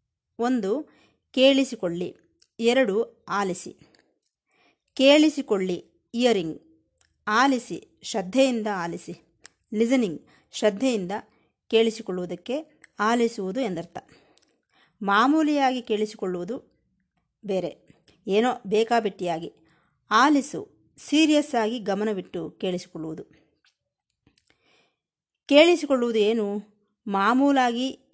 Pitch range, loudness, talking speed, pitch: 190-255 Hz, -24 LUFS, 55 wpm, 215 Hz